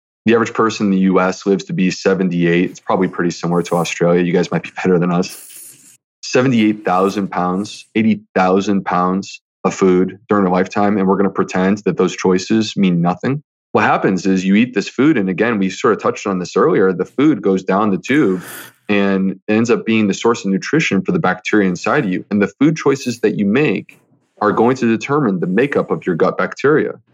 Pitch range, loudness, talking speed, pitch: 90-105 Hz, -16 LUFS, 210 wpm, 95 Hz